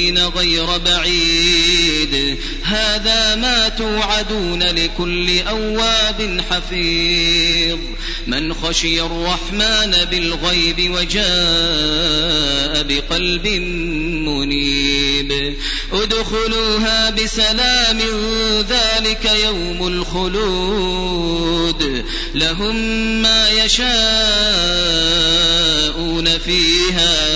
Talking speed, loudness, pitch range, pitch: 55 wpm, -15 LUFS, 165-215 Hz, 175 Hz